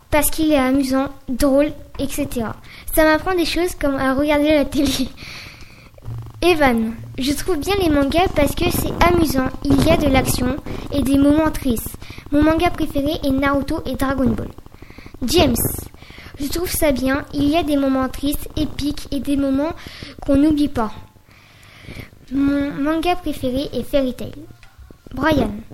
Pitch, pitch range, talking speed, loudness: 280 Hz, 260-305 Hz, 155 wpm, -19 LUFS